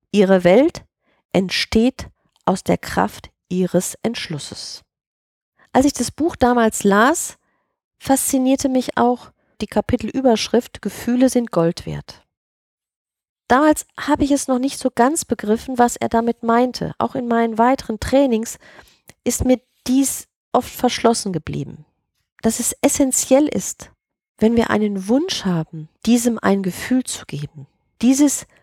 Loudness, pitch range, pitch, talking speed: -18 LUFS, 210-265 Hz, 240 Hz, 130 wpm